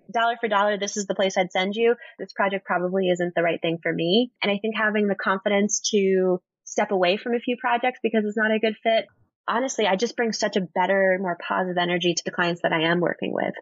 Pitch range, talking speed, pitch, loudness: 185-225 Hz, 245 wpm, 200 Hz, -23 LUFS